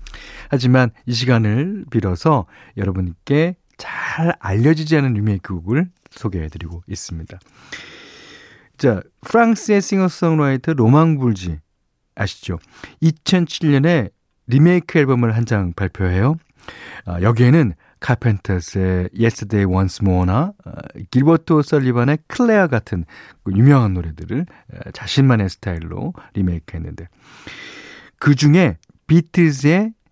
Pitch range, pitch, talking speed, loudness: 95-160 Hz, 120 Hz, 275 characters per minute, -17 LUFS